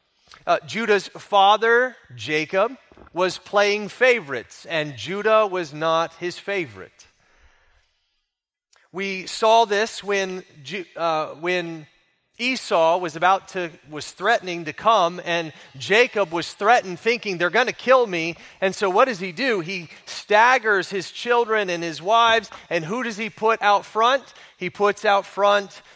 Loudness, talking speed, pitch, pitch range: -21 LUFS, 145 wpm, 195 Hz, 170-220 Hz